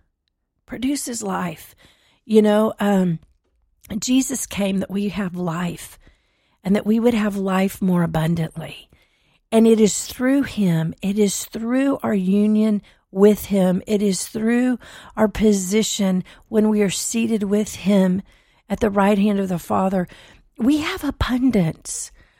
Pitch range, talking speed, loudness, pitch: 180-220 Hz, 140 wpm, -20 LUFS, 200 Hz